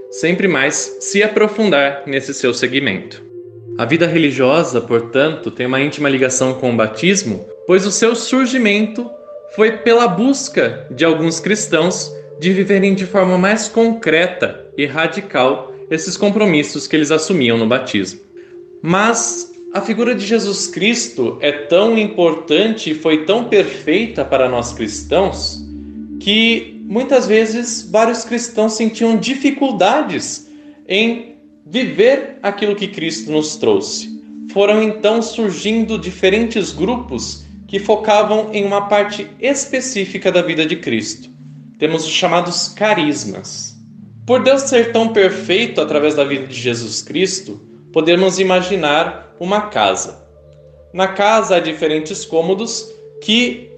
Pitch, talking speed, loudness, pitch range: 195 Hz, 125 wpm, -15 LUFS, 145-225 Hz